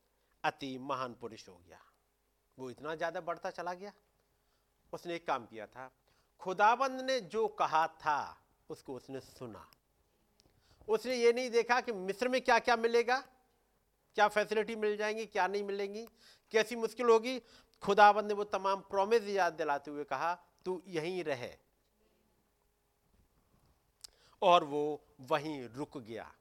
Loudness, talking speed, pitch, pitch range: -33 LUFS, 140 wpm, 190 Hz, 150-225 Hz